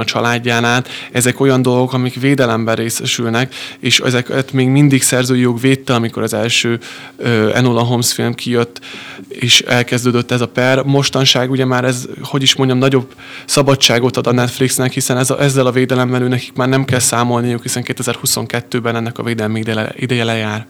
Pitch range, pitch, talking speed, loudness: 120-130 Hz, 125 Hz, 170 wpm, -14 LUFS